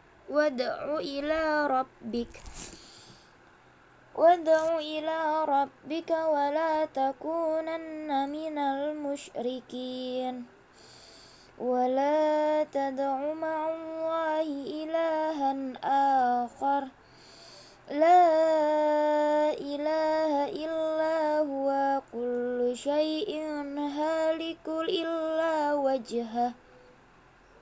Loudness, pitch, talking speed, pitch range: -28 LUFS, 300 Hz, 55 wpm, 275-320 Hz